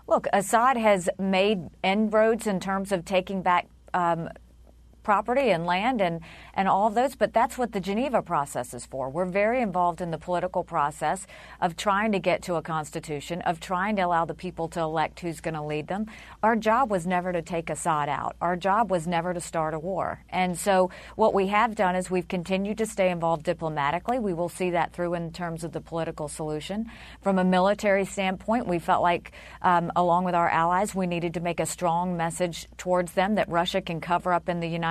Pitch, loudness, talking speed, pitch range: 180 Hz, -26 LUFS, 210 wpm, 165-195 Hz